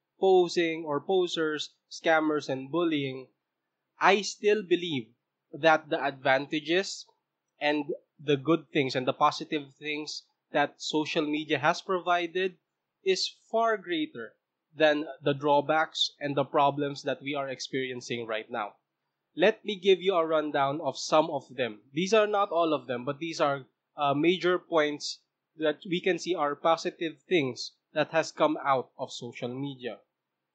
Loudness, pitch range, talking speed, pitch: -28 LUFS, 140-175 Hz, 150 wpm, 155 Hz